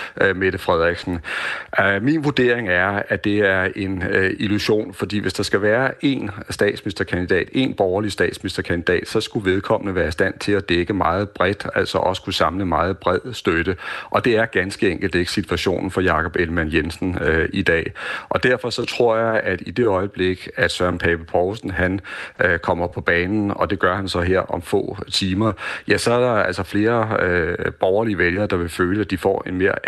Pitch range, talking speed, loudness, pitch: 90-105 Hz, 195 wpm, -20 LUFS, 95 Hz